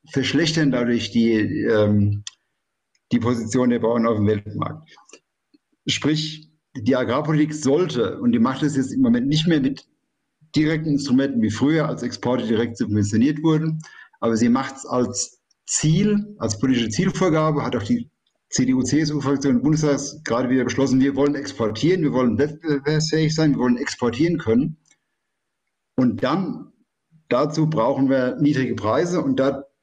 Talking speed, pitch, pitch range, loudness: 145 wpm, 140 Hz, 120-155 Hz, -21 LUFS